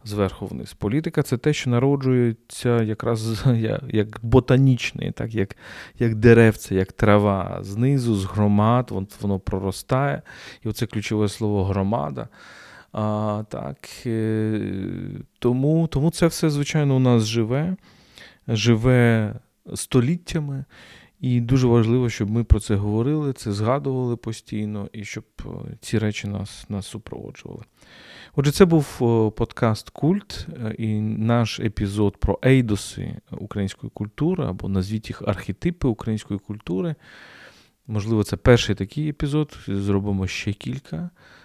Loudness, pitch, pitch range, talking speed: -22 LUFS, 115 Hz, 105-130 Hz, 120 wpm